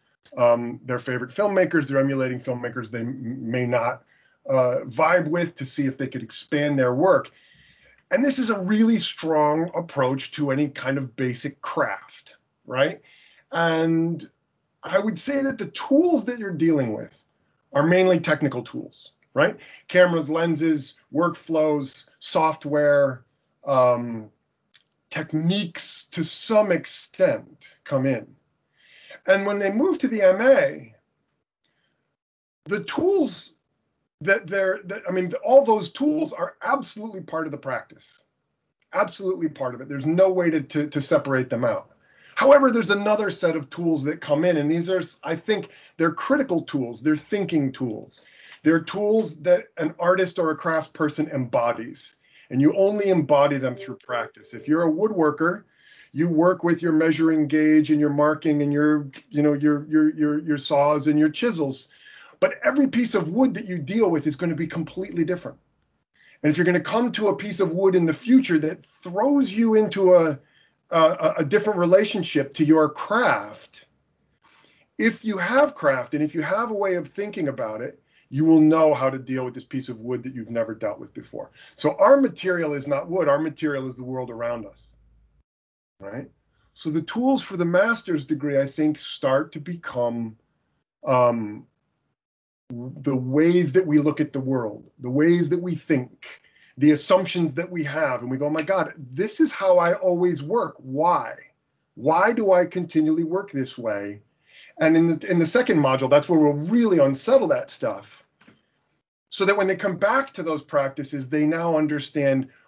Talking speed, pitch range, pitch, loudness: 170 wpm, 140-185 Hz, 160 Hz, -22 LUFS